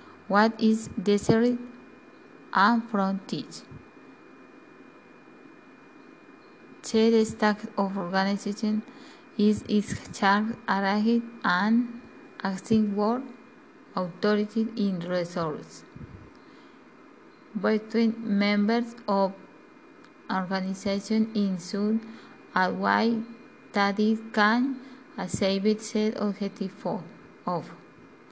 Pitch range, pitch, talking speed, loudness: 200-235 Hz, 215 Hz, 70 wpm, -26 LUFS